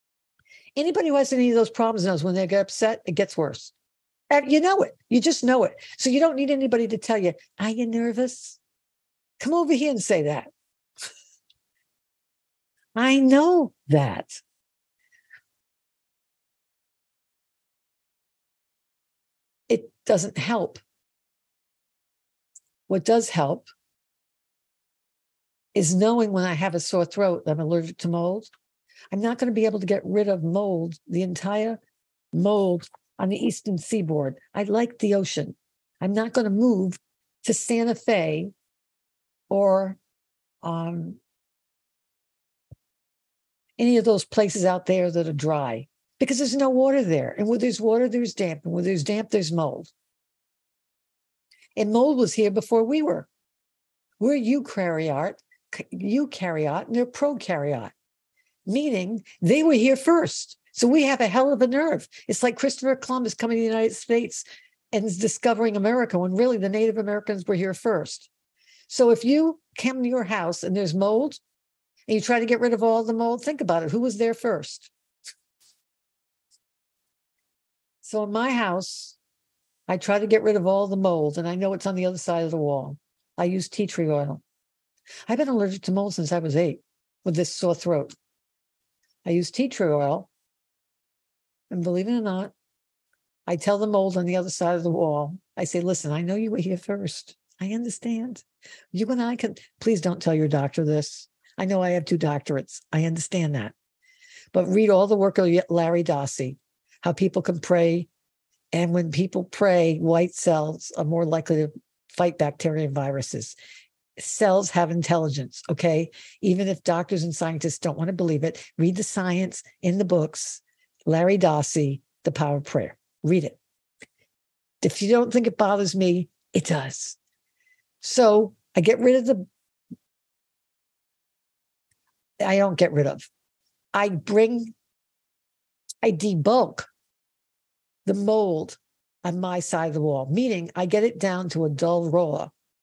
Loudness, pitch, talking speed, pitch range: -24 LUFS, 195 Hz, 160 wpm, 170-230 Hz